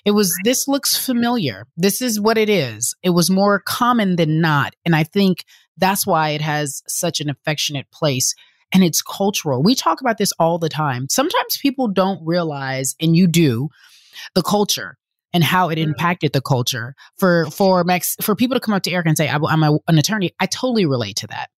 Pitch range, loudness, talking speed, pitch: 150-200 Hz, -18 LUFS, 205 wpm, 175 Hz